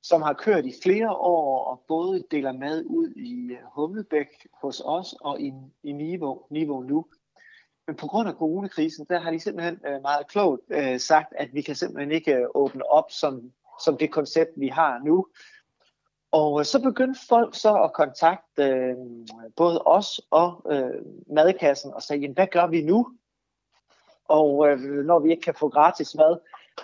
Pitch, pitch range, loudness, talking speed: 155 Hz, 145-180 Hz, -24 LUFS, 170 wpm